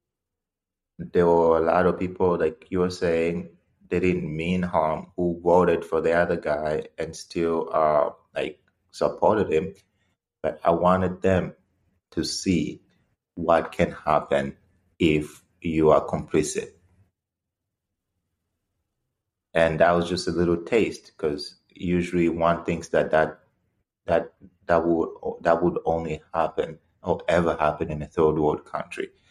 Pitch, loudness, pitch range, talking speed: 85 Hz, -24 LUFS, 80-90 Hz, 140 wpm